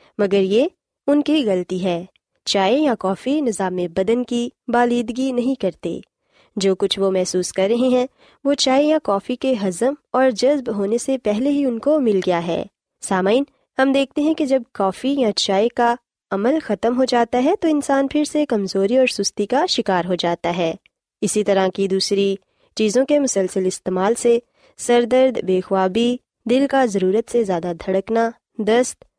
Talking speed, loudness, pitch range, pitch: 180 wpm, -19 LUFS, 195-265 Hz, 230 Hz